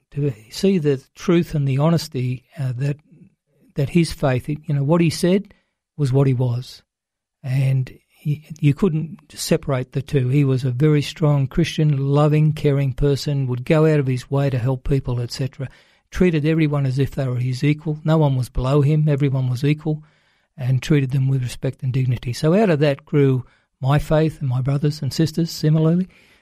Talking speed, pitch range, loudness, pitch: 190 wpm, 135-155 Hz, -20 LUFS, 145 Hz